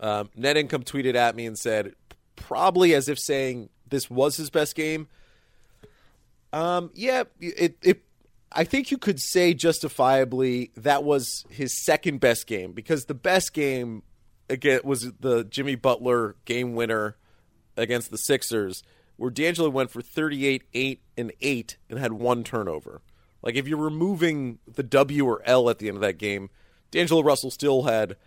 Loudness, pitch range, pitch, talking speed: -25 LUFS, 115-150 Hz, 130 Hz, 165 wpm